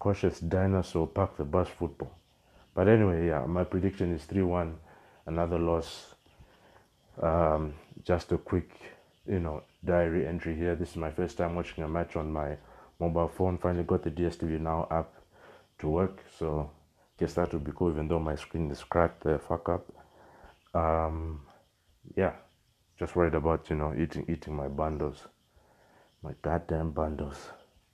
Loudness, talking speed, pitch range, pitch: -31 LUFS, 165 wpm, 80-90 Hz, 85 Hz